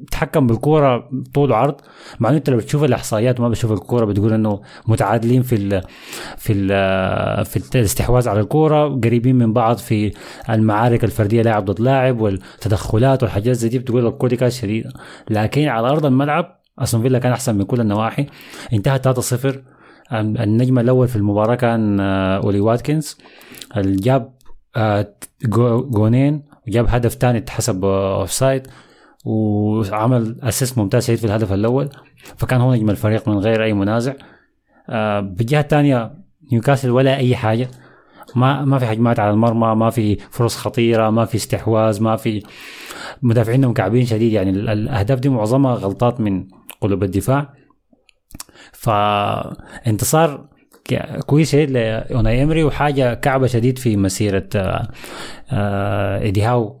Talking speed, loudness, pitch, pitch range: 135 wpm, -17 LUFS, 115 Hz, 105-130 Hz